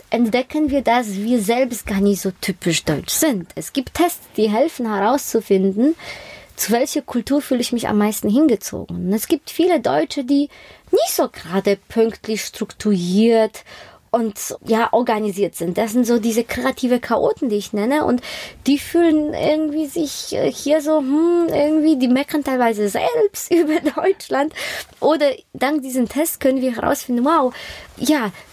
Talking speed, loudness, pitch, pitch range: 155 wpm, -19 LUFS, 255 Hz, 220-305 Hz